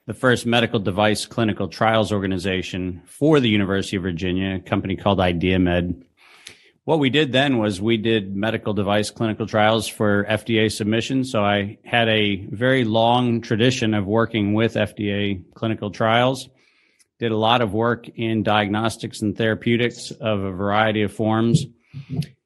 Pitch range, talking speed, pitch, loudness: 100-115 Hz, 150 wpm, 110 Hz, -21 LUFS